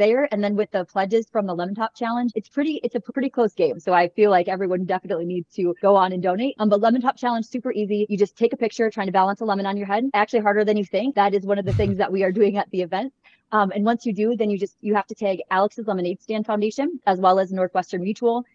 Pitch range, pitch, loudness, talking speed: 190-230 Hz, 205 Hz, -22 LUFS, 290 wpm